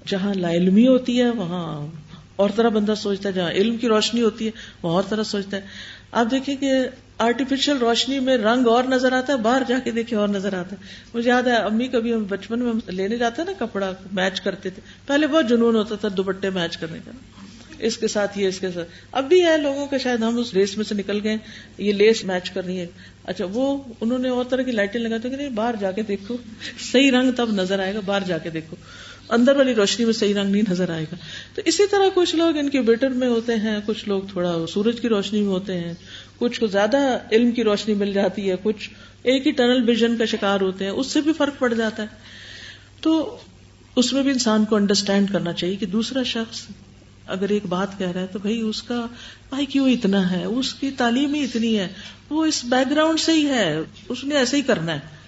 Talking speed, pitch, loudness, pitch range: 235 wpm, 220 Hz, -21 LUFS, 195-255 Hz